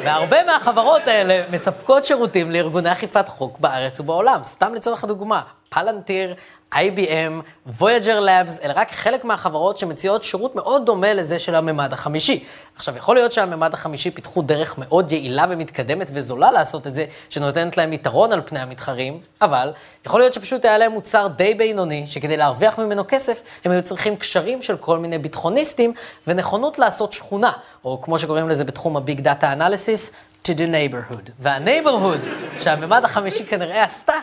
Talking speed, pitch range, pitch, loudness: 155 wpm, 155-215 Hz, 180 Hz, -19 LUFS